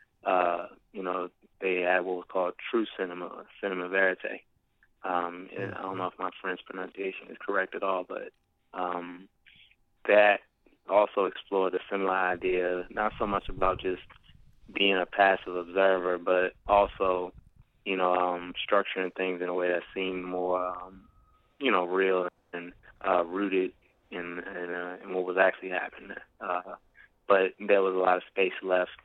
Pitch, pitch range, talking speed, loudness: 90 Hz, 90-95 Hz, 165 wpm, -29 LUFS